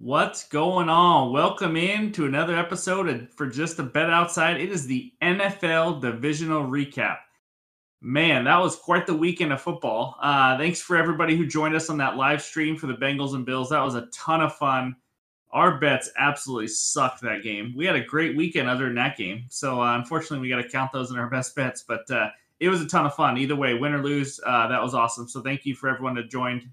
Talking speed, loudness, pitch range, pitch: 225 wpm, -24 LUFS, 130-165 Hz, 145 Hz